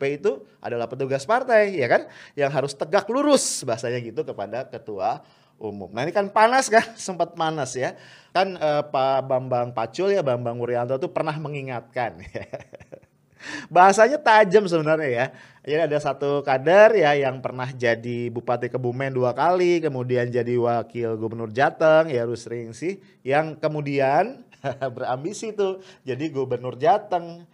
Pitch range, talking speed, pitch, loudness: 125-180 Hz, 145 wpm, 140 Hz, -22 LUFS